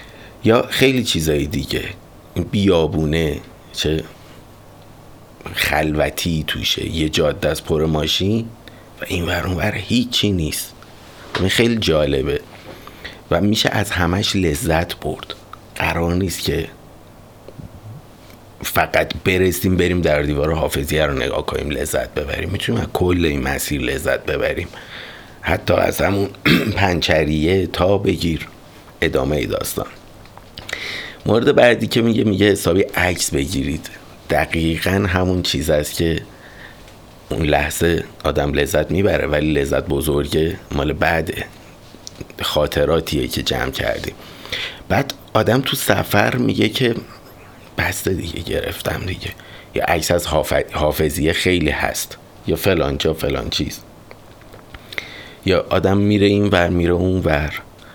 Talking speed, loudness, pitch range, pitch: 115 wpm, -18 LUFS, 80-105 Hz, 90 Hz